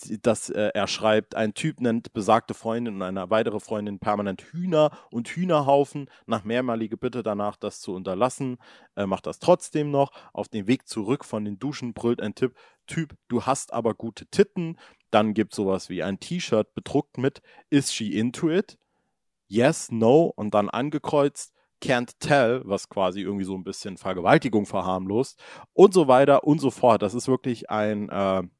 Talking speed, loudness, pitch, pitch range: 175 wpm, -25 LUFS, 115 Hz, 105-140 Hz